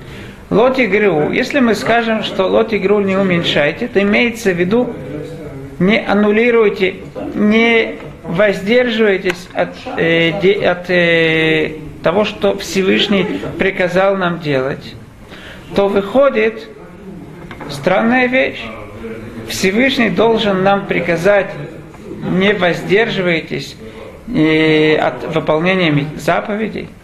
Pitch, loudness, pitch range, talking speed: 190 Hz, -14 LUFS, 160-210 Hz, 90 wpm